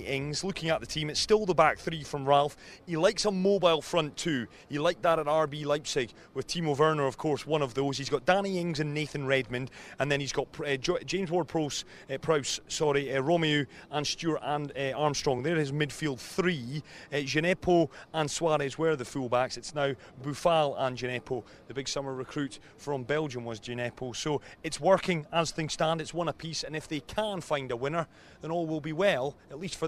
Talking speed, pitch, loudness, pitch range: 210 wpm, 150 Hz, -30 LUFS, 140-165 Hz